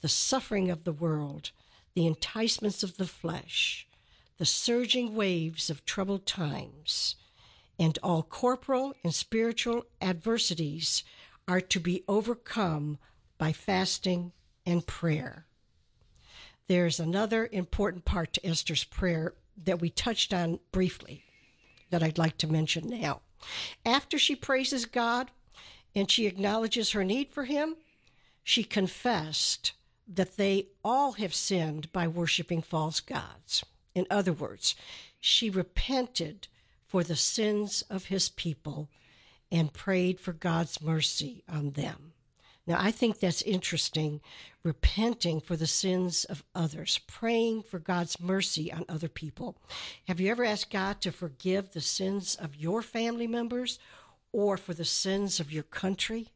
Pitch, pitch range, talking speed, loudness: 185 Hz, 160-215 Hz, 135 wpm, -30 LUFS